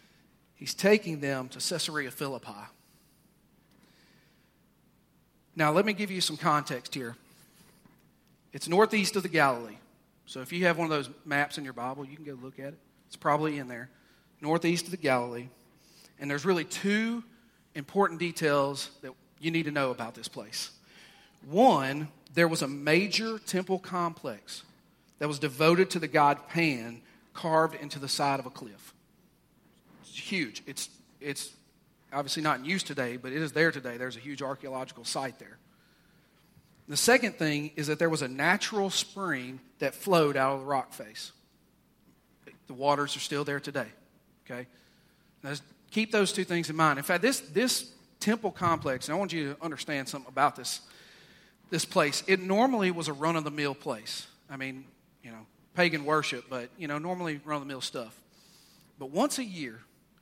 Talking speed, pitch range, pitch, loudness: 170 wpm, 135-175 Hz, 150 Hz, -29 LUFS